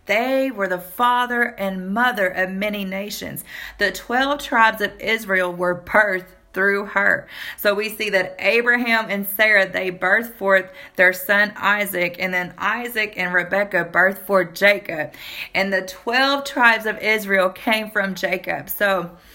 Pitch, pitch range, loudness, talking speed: 200 Hz, 185-220 Hz, -19 LUFS, 150 wpm